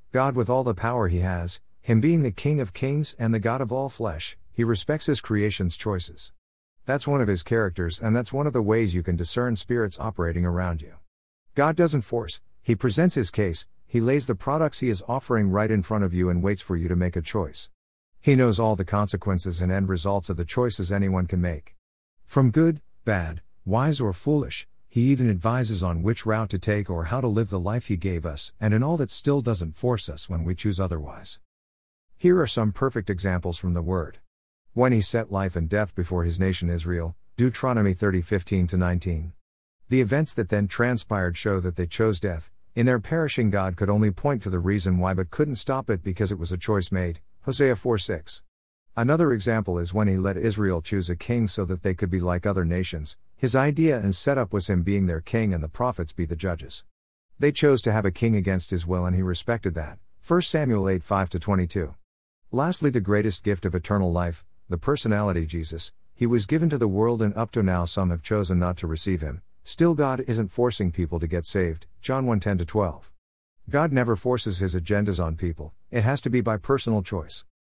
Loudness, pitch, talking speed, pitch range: -25 LUFS, 100 Hz, 215 wpm, 90-120 Hz